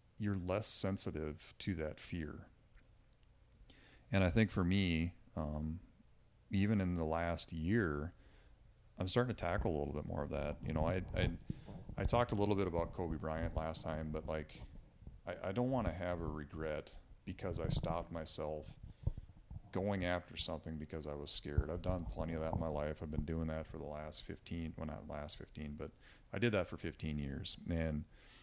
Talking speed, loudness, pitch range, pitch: 190 wpm, -40 LUFS, 80-95 Hz, 85 Hz